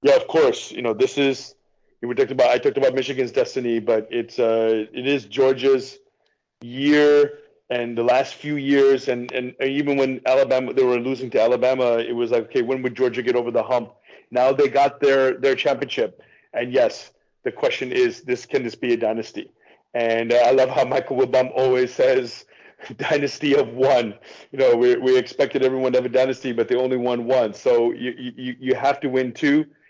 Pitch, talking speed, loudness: 130 Hz, 200 wpm, -20 LUFS